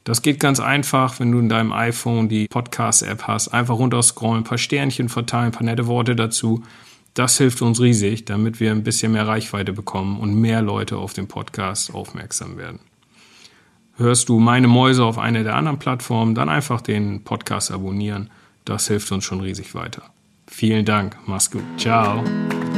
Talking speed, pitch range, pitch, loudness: 175 wpm, 105-120 Hz, 115 Hz, -19 LUFS